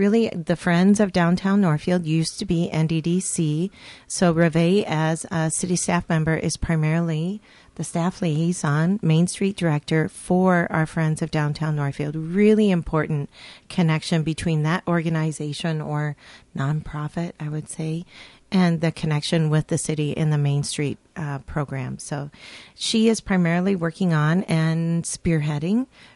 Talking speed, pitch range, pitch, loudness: 140 wpm, 155-180 Hz, 165 Hz, -22 LUFS